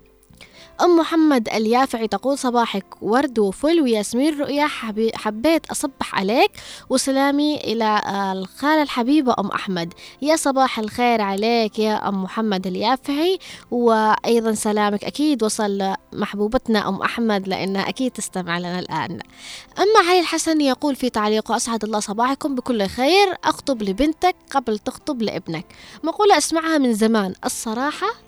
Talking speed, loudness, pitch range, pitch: 125 wpm, -20 LUFS, 210-295 Hz, 235 Hz